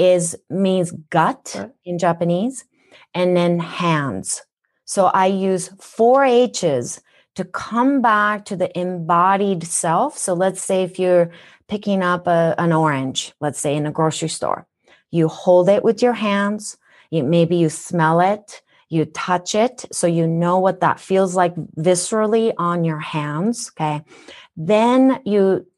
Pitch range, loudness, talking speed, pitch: 165-205 Hz, -18 LUFS, 150 wpm, 180 Hz